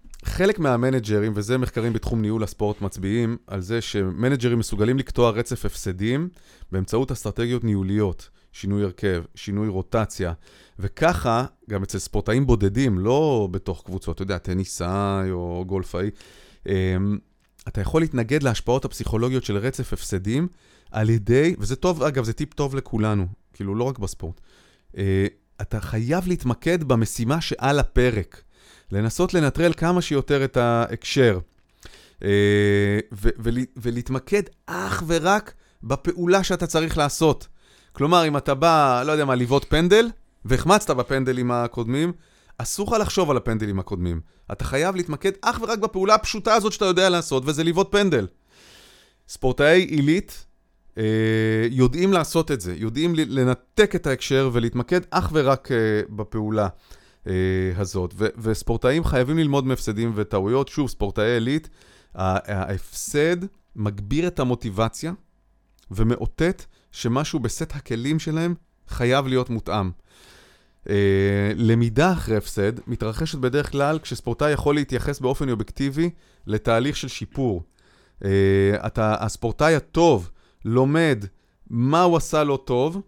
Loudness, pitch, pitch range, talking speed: -22 LUFS, 120 Hz, 100-145 Hz, 125 wpm